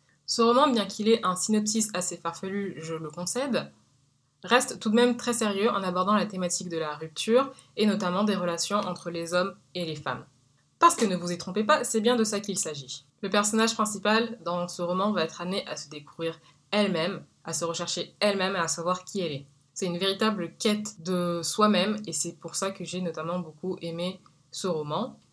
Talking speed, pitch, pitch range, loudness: 210 wpm, 180 Hz, 170-210 Hz, -26 LUFS